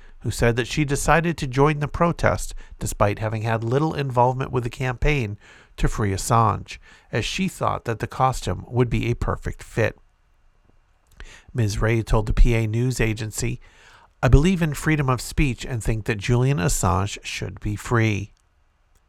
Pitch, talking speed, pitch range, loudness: 120 Hz, 165 wpm, 105-135 Hz, -23 LUFS